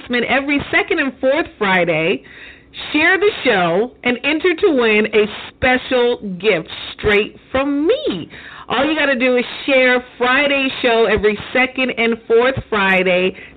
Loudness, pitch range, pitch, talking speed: -16 LUFS, 220-285 Hz, 255 Hz, 140 wpm